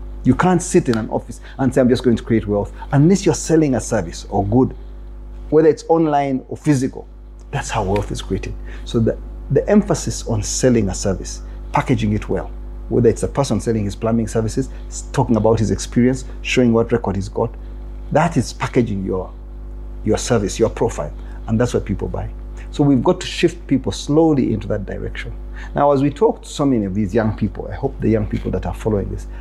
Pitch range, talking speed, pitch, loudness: 100-130 Hz, 210 wpm, 115 Hz, -18 LUFS